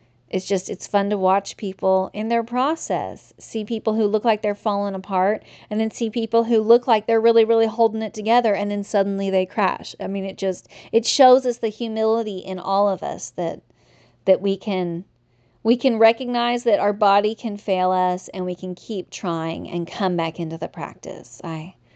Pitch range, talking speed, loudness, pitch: 190-225 Hz, 200 wpm, -21 LUFS, 205 Hz